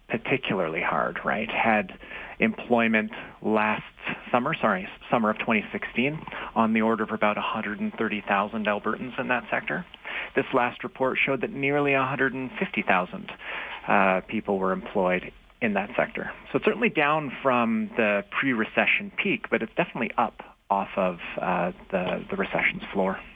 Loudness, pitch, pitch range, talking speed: -26 LUFS, 110 Hz, 105-130 Hz, 140 wpm